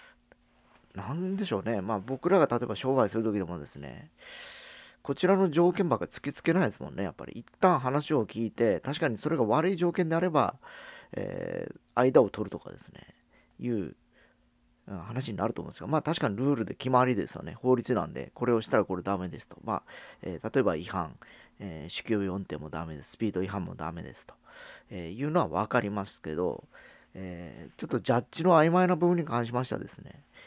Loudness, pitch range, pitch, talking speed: -29 LUFS, 100-165 Hz, 125 Hz, 395 characters per minute